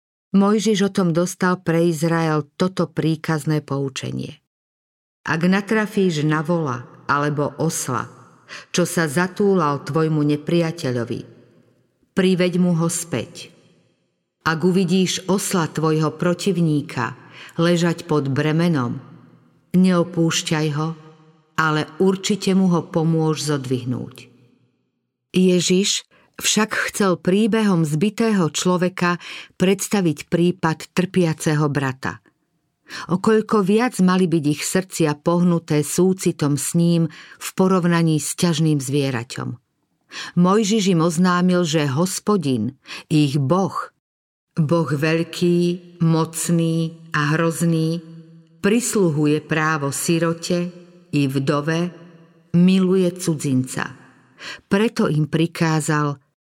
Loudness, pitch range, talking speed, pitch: -20 LUFS, 150-180 Hz, 95 wpm, 165 Hz